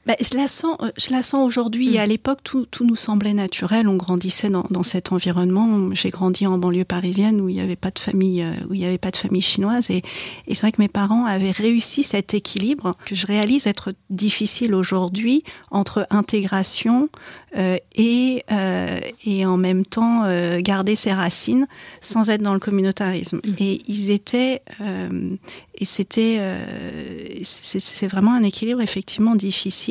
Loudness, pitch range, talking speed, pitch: -20 LUFS, 190-225 Hz, 185 wpm, 205 Hz